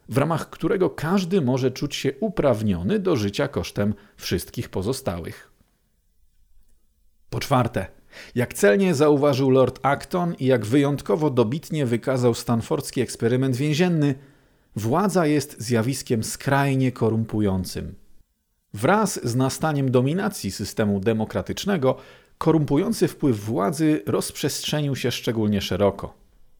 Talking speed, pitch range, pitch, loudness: 105 wpm, 110-150 Hz, 130 Hz, -23 LUFS